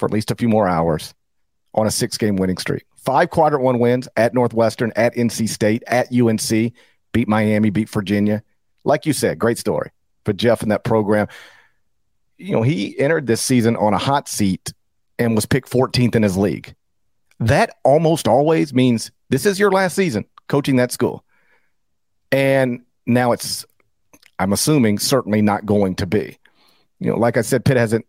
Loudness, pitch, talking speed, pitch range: -18 LUFS, 115 Hz, 180 wpm, 105-130 Hz